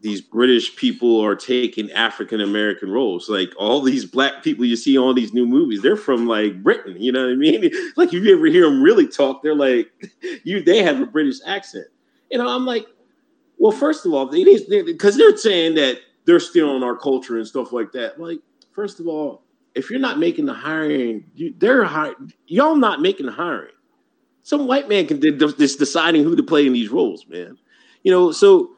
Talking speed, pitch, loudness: 215 wpm, 210 Hz, -17 LUFS